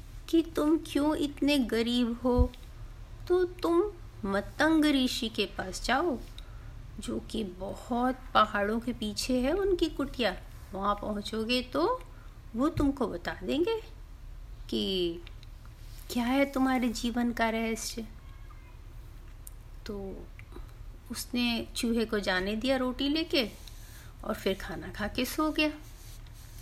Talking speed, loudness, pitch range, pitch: 115 wpm, -30 LUFS, 205-290 Hz, 240 Hz